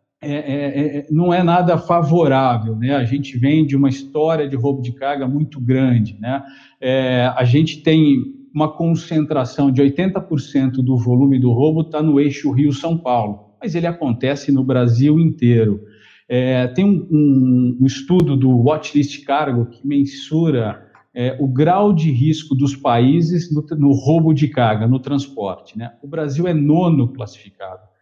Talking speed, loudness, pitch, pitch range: 160 wpm, -17 LUFS, 140 Hz, 130-155 Hz